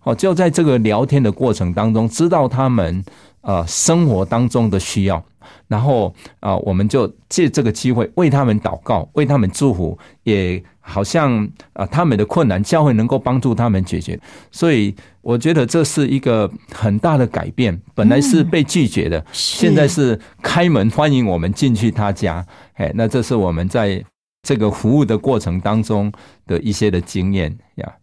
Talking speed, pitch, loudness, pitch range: 260 characters per minute, 110 Hz, -16 LUFS, 100-140 Hz